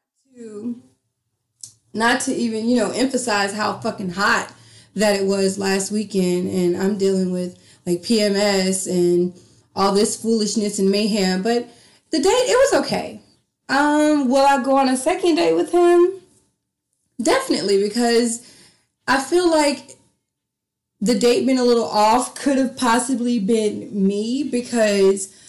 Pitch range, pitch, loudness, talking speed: 195-255 Hz, 220 Hz, -19 LUFS, 140 wpm